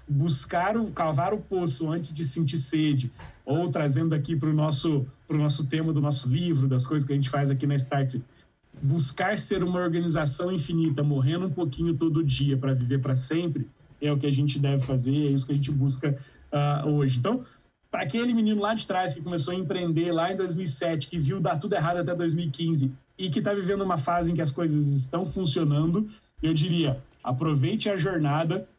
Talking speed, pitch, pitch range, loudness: 200 wpm, 155 Hz, 140-175 Hz, -26 LUFS